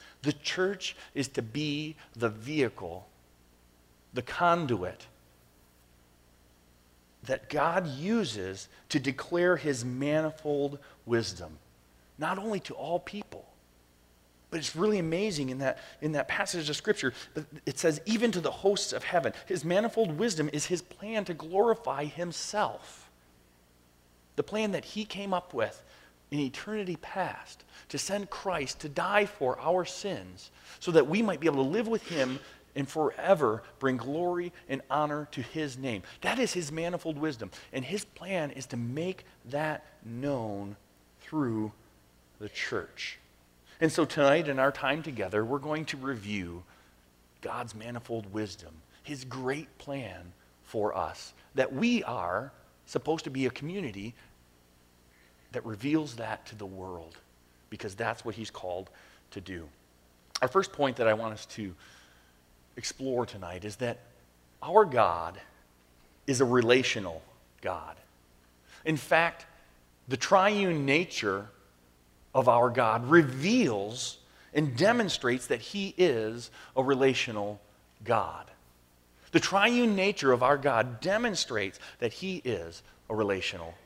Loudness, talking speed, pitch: -30 LUFS, 135 wpm, 130 Hz